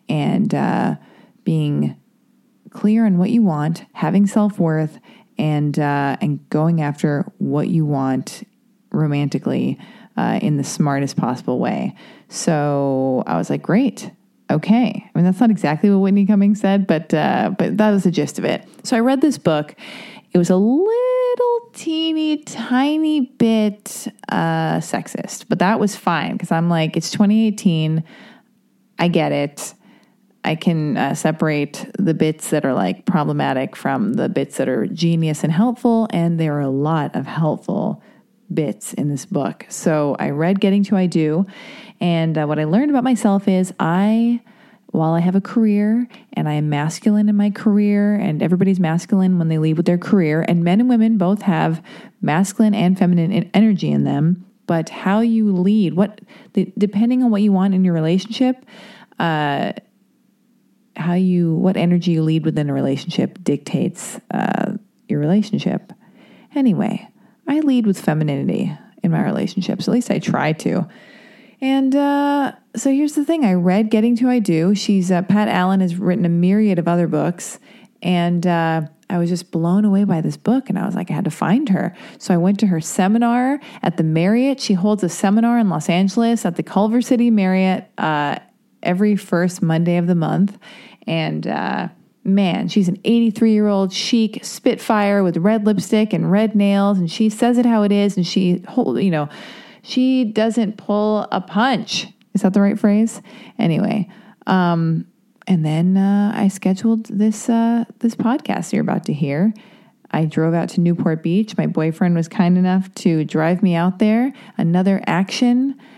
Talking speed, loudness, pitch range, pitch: 170 wpm, -18 LUFS, 170-220 Hz, 200 Hz